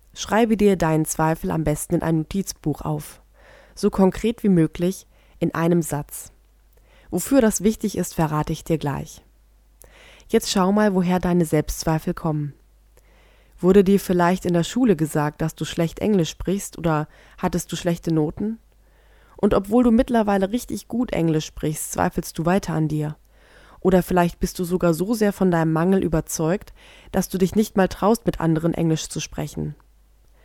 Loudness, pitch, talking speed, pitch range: -22 LUFS, 175 Hz, 165 wpm, 160-195 Hz